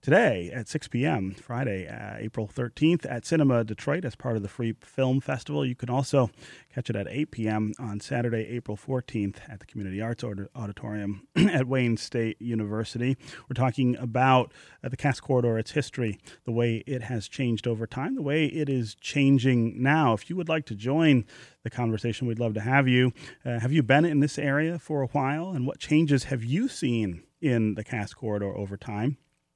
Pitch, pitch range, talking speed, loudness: 125 Hz, 110-140 Hz, 195 wpm, -27 LUFS